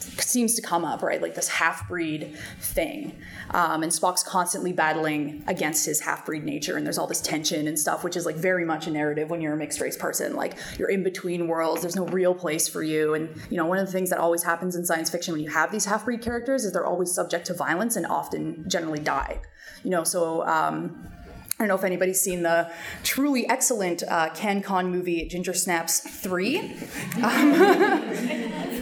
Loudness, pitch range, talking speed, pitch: -25 LUFS, 160-185 Hz, 200 wpm, 175 Hz